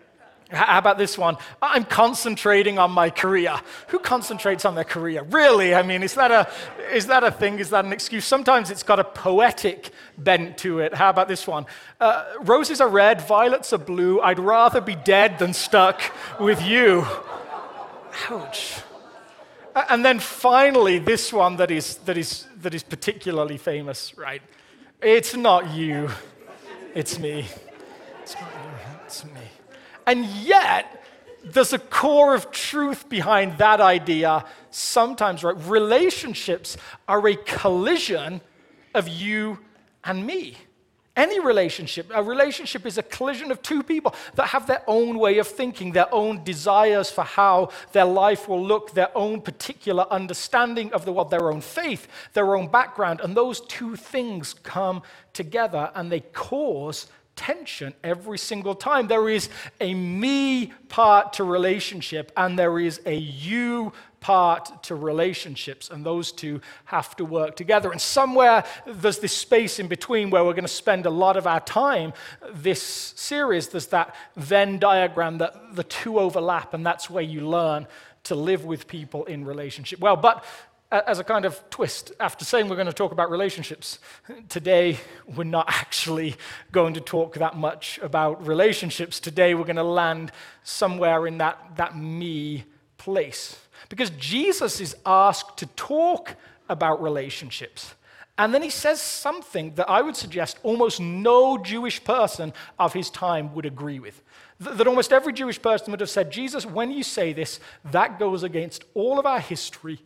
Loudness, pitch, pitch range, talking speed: -22 LUFS, 190 Hz, 170-230 Hz, 160 wpm